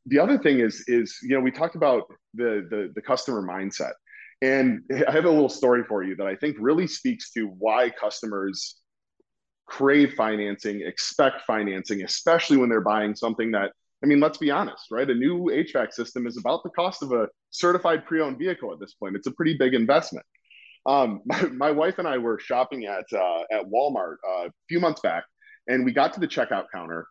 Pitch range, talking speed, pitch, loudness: 105-155 Hz, 205 wpm, 130 Hz, -24 LUFS